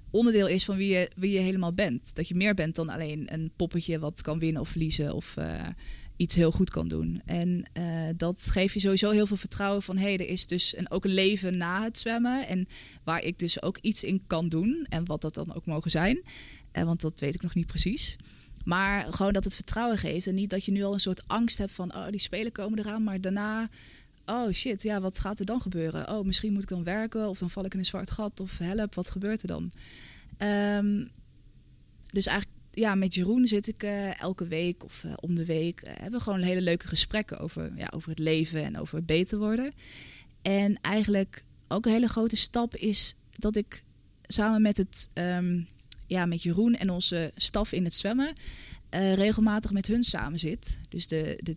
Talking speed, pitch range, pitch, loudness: 225 wpm, 170-210 Hz, 190 Hz, -26 LUFS